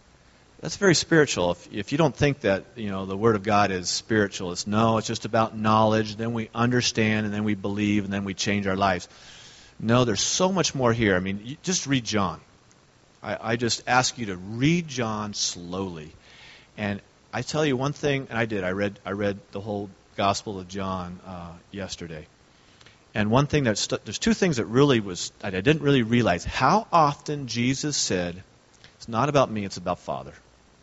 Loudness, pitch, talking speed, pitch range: -25 LUFS, 110 Hz, 200 wpm, 95-125 Hz